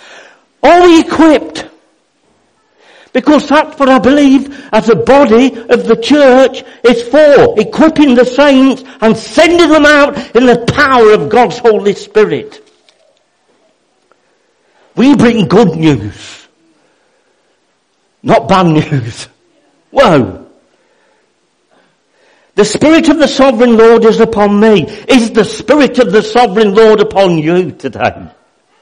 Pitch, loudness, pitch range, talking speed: 240 Hz, -8 LUFS, 215-280 Hz, 115 wpm